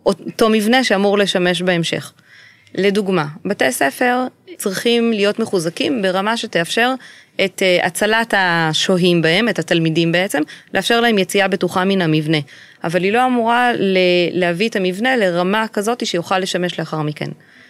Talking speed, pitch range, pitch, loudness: 130 wpm, 175-225 Hz, 195 Hz, -16 LUFS